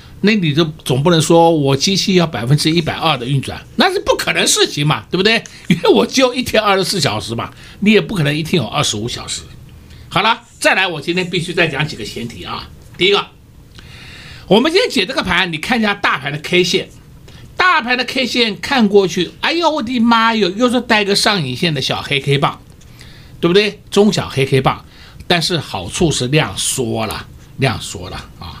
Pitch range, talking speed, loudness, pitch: 145-220 Hz, 290 characters per minute, -14 LUFS, 175 Hz